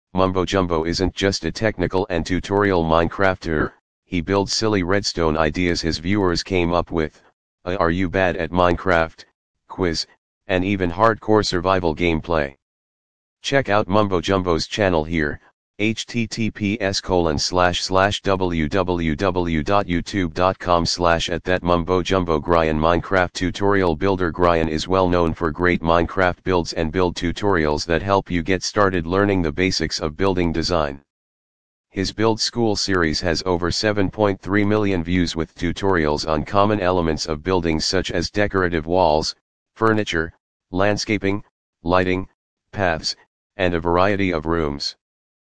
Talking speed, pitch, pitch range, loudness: 135 wpm, 90 Hz, 85-100 Hz, -20 LUFS